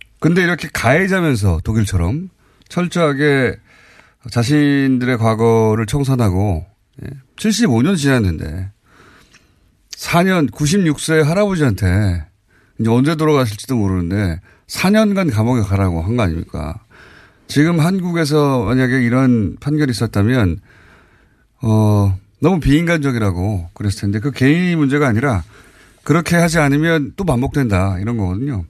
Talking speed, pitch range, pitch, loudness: 275 characters per minute, 100-150 Hz, 125 Hz, -16 LUFS